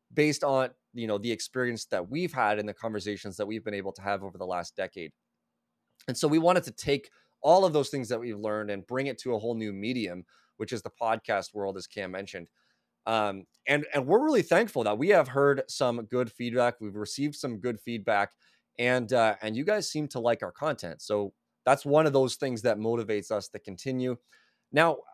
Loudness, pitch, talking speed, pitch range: -29 LUFS, 120 Hz, 215 wpm, 105-135 Hz